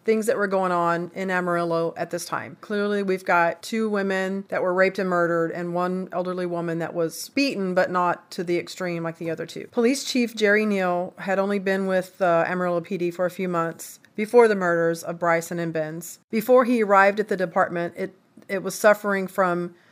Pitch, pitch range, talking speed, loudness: 185 Hz, 170-200 Hz, 210 wpm, -23 LUFS